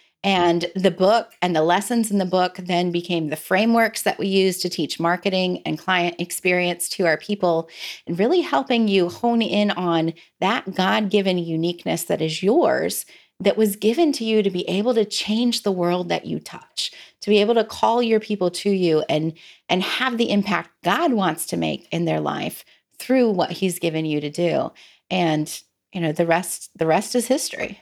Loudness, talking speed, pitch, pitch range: -21 LUFS, 195 wpm, 185 Hz, 175-210 Hz